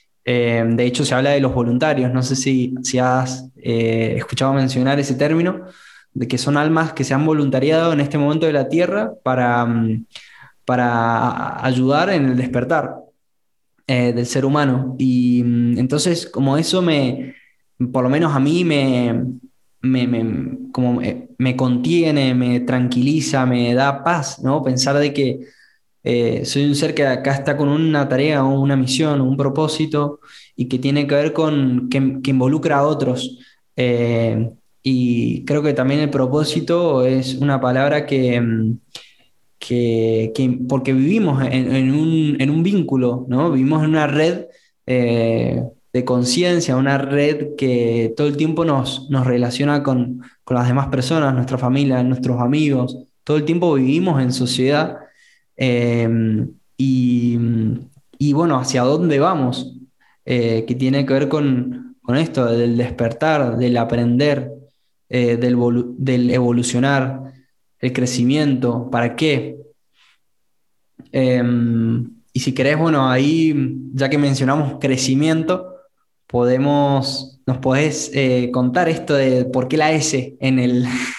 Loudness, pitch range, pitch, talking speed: -18 LUFS, 125-145 Hz, 130 Hz, 145 wpm